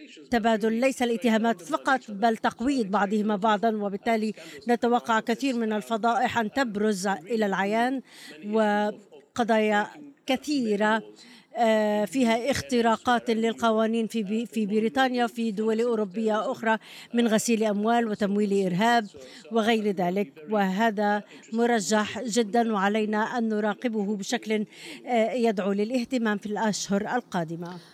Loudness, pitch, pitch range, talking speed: -26 LUFS, 225 Hz, 210-235 Hz, 100 wpm